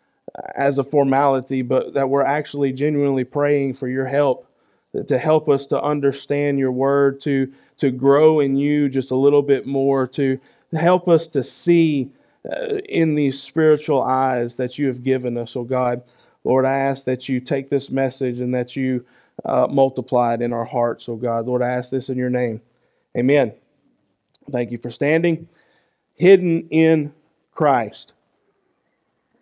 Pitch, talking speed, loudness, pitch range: 135 Hz, 165 wpm, -19 LUFS, 130-145 Hz